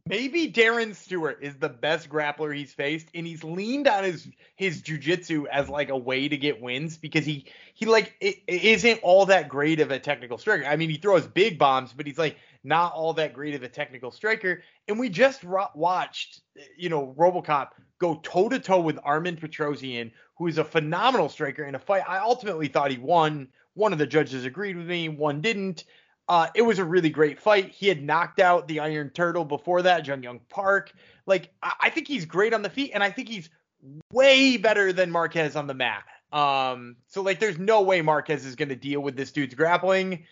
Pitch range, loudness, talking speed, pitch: 145-195 Hz, -24 LUFS, 215 wpm, 165 Hz